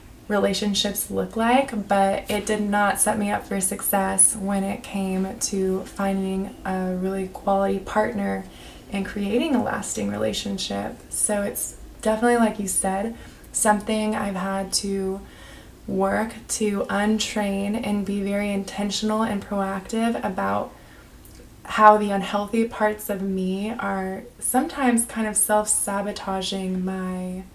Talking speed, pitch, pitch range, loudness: 130 wpm, 200 Hz, 195-215 Hz, -23 LUFS